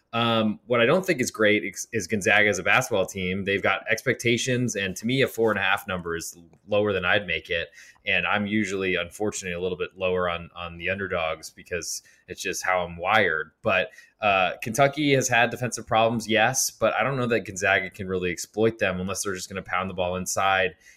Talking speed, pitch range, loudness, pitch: 220 wpm, 90-115 Hz, -24 LUFS, 100 Hz